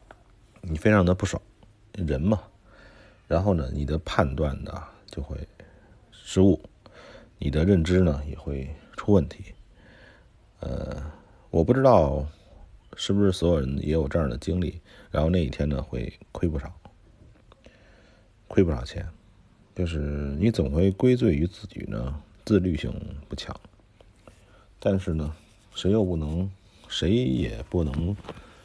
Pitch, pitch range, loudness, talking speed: 90 Hz, 80-105 Hz, -26 LUFS, 185 characters per minute